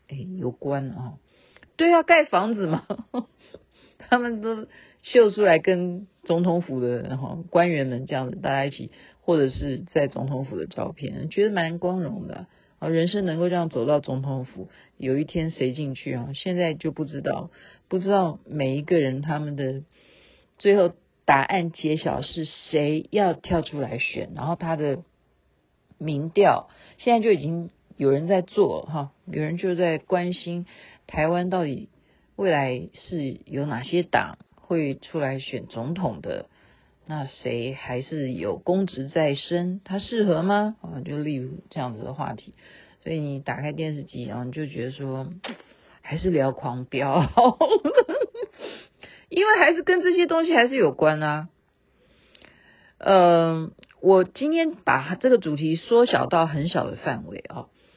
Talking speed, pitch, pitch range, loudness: 215 characters per minute, 165 Hz, 140-185 Hz, -24 LUFS